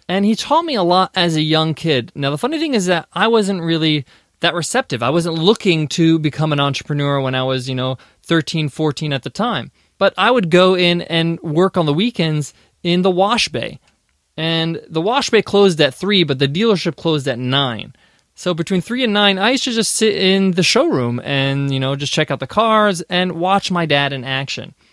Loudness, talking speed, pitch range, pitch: -16 LUFS, 220 wpm, 145-195 Hz, 170 Hz